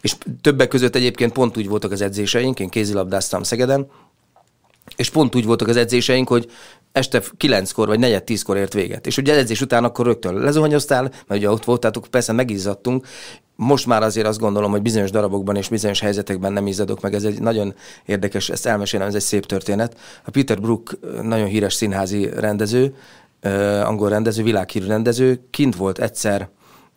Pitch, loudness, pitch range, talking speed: 110 Hz, -19 LUFS, 100-125 Hz, 170 wpm